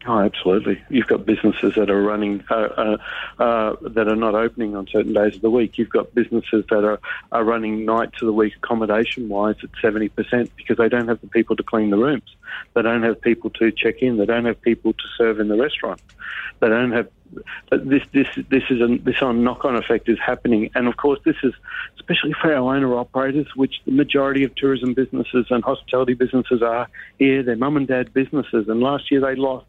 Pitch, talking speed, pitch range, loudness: 115 Hz, 220 wpm, 110-130 Hz, -20 LUFS